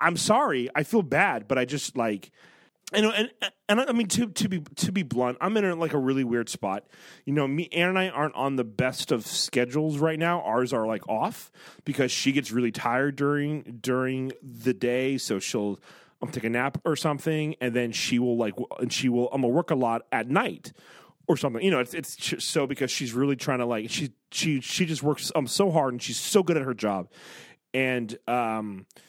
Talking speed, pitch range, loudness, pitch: 235 wpm, 125-160 Hz, -27 LUFS, 135 Hz